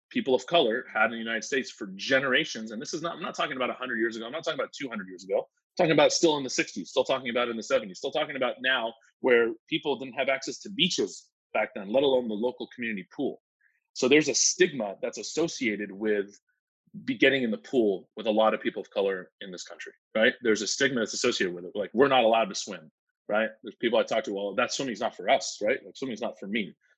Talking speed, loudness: 255 wpm, -27 LUFS